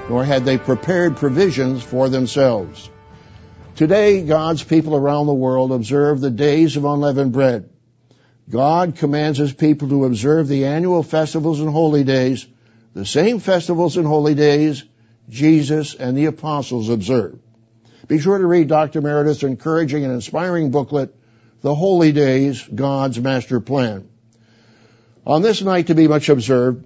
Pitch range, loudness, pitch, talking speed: 130-155 Hz, -17 LUFS, 145 Hz, 145 wpm